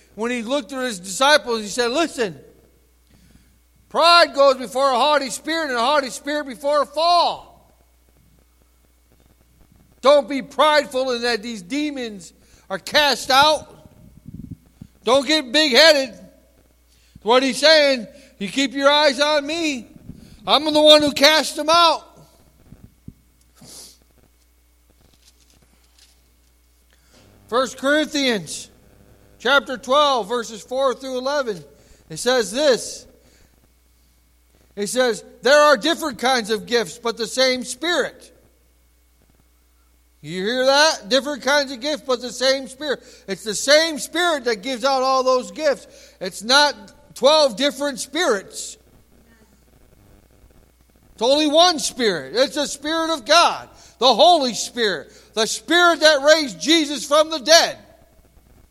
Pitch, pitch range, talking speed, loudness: 260 Hz, 185-290 Hz, 125 wpm, -18 LUFS